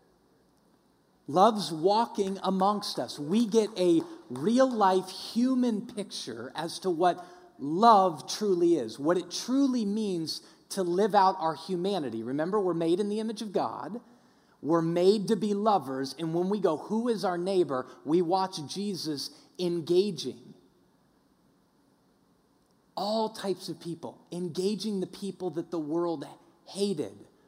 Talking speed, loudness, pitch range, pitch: 135 wpm, -28 LUFS, 170-210 Hz, 190 Hz